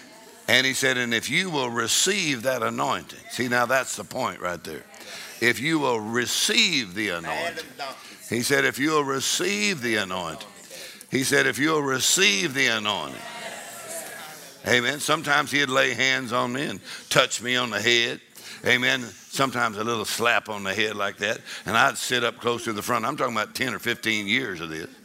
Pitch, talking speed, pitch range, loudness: 125 Hz, 185 wpm, 115-135 Hz, -23 LUFS